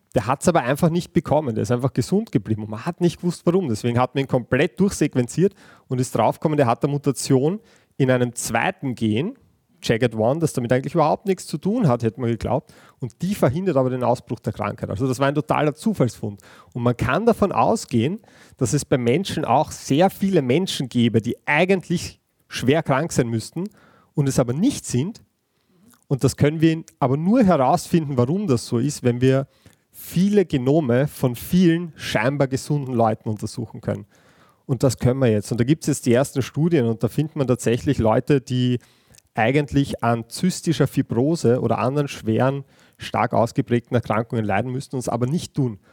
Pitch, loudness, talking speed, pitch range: 135 Hz, -21 LUFS, 190 wpm, 120-155 Hz